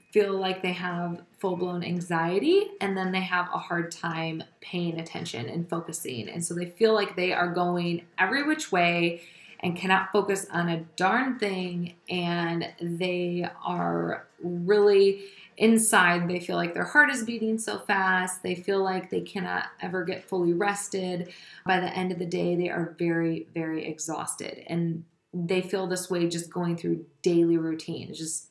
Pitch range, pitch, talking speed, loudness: 170-190 Hz, 180 Hz, 170 wpm, -27 LUFS